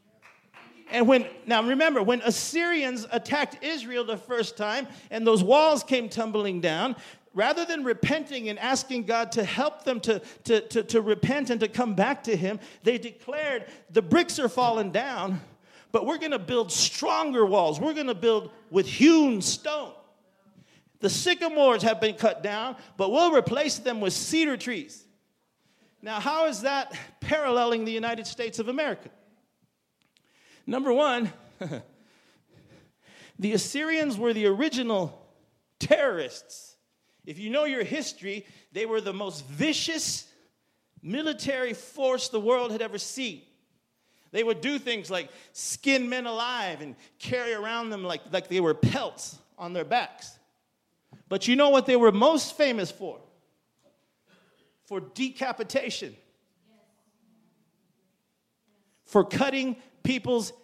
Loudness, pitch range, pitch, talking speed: -26 LUFS, 215-270 Hz, 235 Hz, 135 wpm